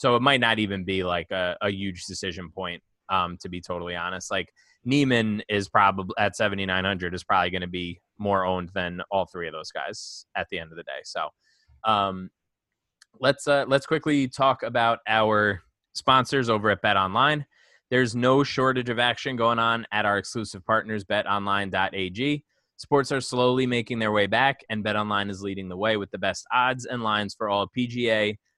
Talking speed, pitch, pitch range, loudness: 195 wpm, 105 Hz, 95-125 Hz, -25 LUFS